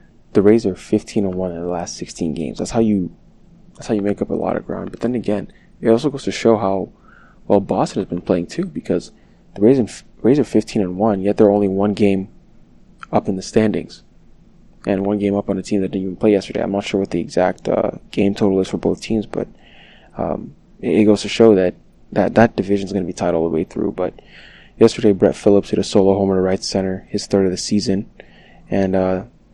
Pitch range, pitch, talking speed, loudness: 95-110 Hz, 100 Hz, 240 wpm, -18 LUFS